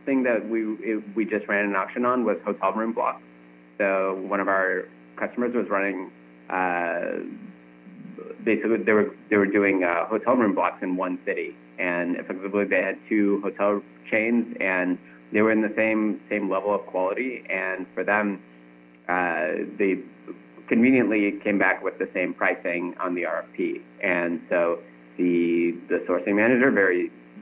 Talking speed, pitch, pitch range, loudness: 160 wpm, 95 Hz, 85-105 Hz, -24 LUFS